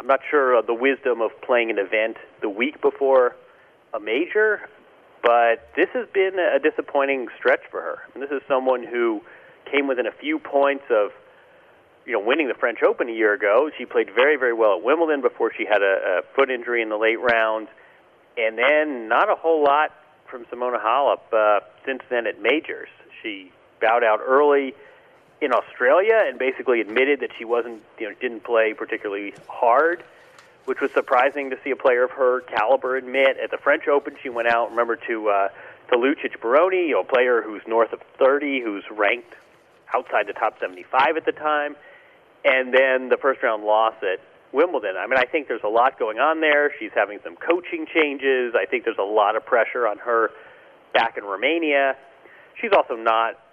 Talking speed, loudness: 190 wpm, -21 LUFS